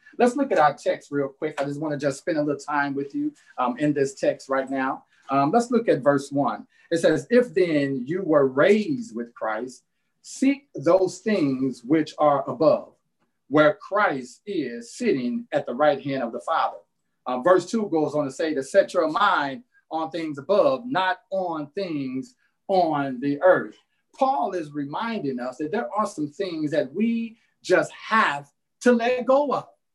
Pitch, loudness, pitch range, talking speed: 165 Hz, -24 LUFS, 140-230 Hz, 185 wpm